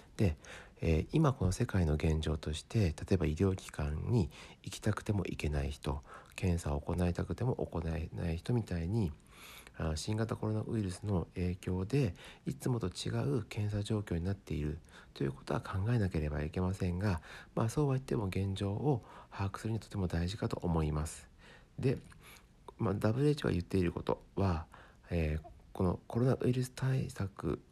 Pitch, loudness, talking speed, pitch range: 95 Hz, -36 LUFS, 330 characters per minute, 80-110 Hz